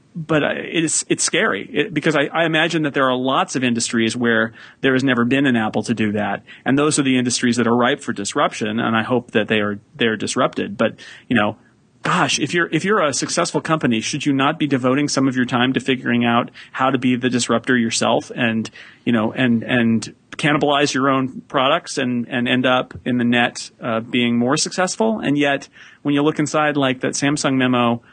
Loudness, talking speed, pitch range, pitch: -18 LUFS, 220 wpm, 120-145 Hz, 130 Hz